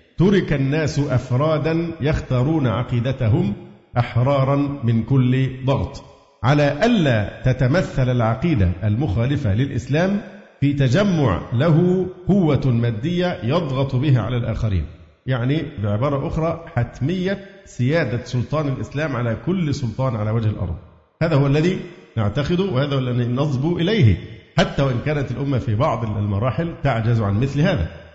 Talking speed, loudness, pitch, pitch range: 120 wpm, -20 LUFS, 135 Hz, 115-155 Hz